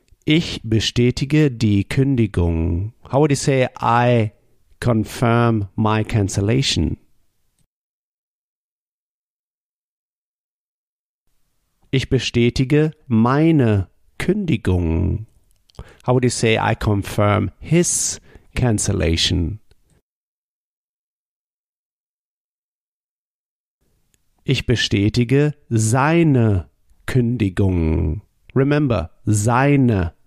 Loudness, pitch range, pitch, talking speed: -18 LUFS, 100-130 Hz, 115 Hz, 60 wpm